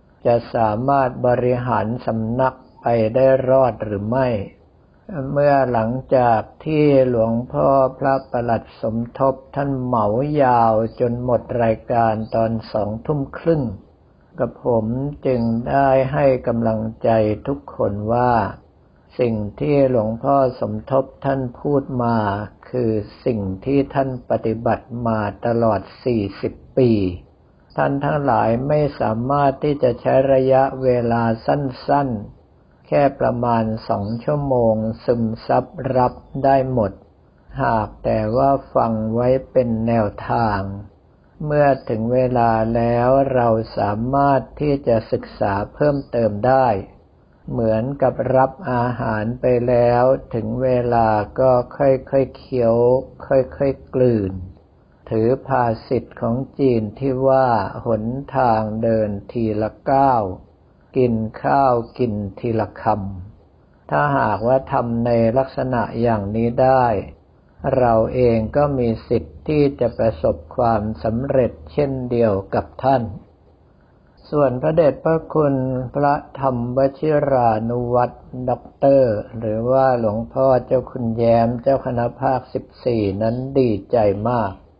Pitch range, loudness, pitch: 110-130 Hz, -19 LUFS, 120 Hz